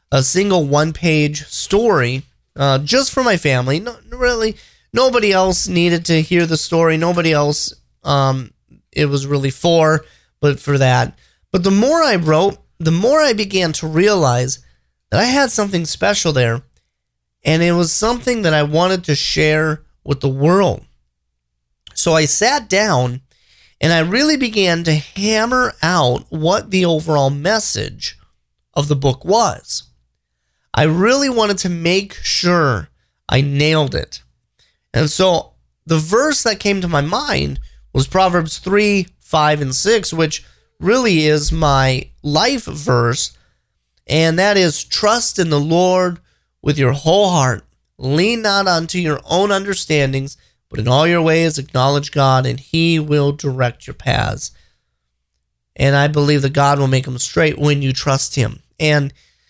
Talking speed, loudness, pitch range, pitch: 150 wpm, -15 LUFS, 135-185 Hz, 155 Hz